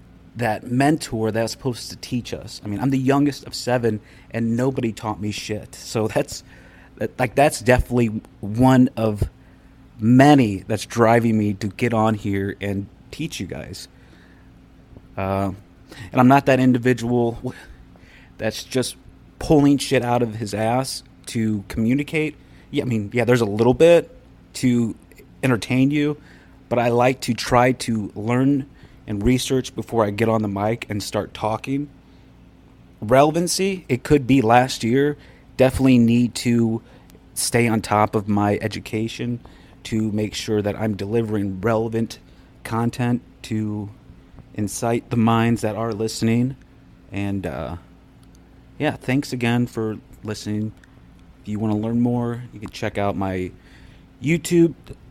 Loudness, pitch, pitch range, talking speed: -21 LUFS, 115 Hz, 105-130 Hz, 145 wpm